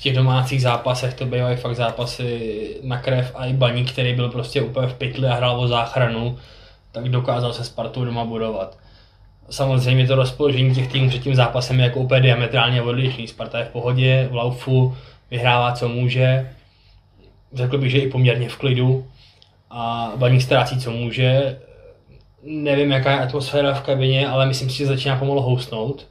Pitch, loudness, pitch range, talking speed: 125 Hz, -20 LUFS, 120-130 Hz, 175 wpm